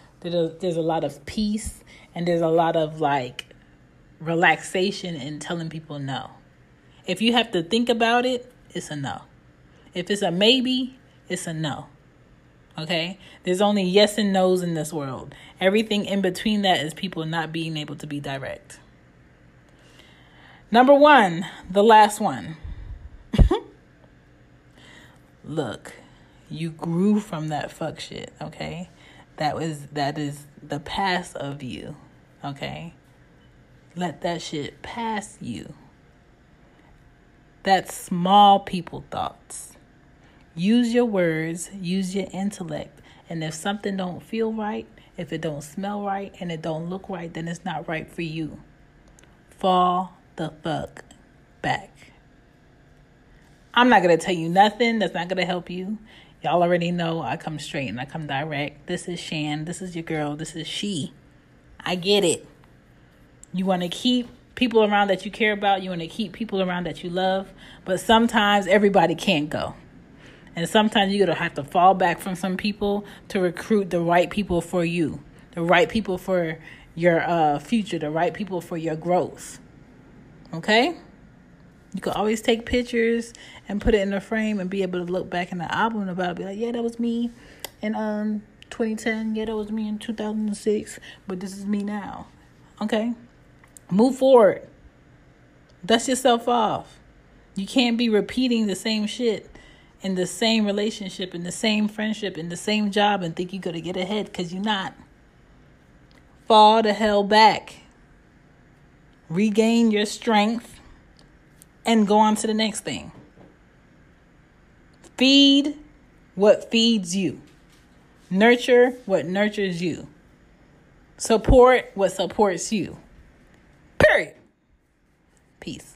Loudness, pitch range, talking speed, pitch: -22 LUFS, 165-215 Hz, 150 wpm, 185 Hz